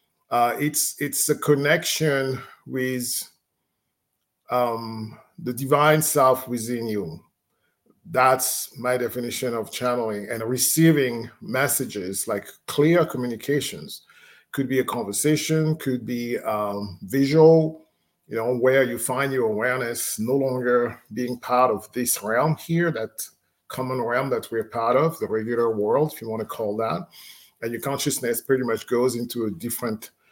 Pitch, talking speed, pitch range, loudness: 125 Hz, 140 wpm, 120-145 Hz, -23 LUFS